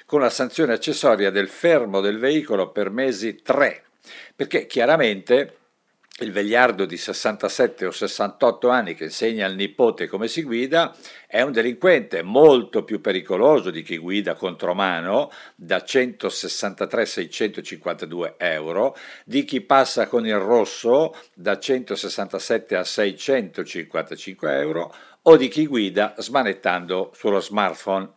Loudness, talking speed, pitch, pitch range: -21 LUFS, 130 wpm, 120 Hz, 100-135 Hz